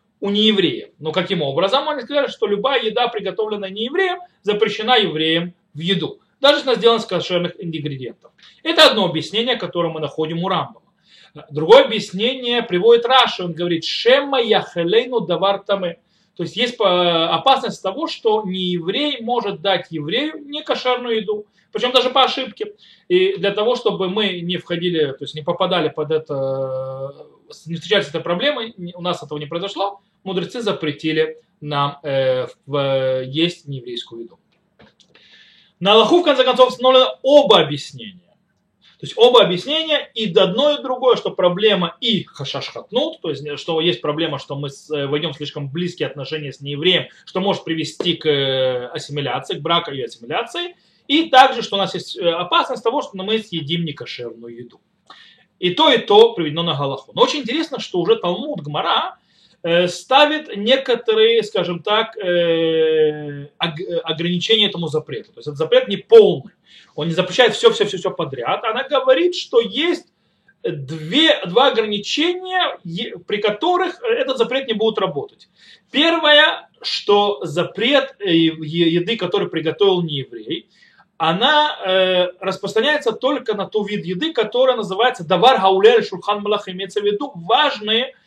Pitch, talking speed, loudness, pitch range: 195 Hz, 150 wpm, -18 LUFS, 165-255 Hz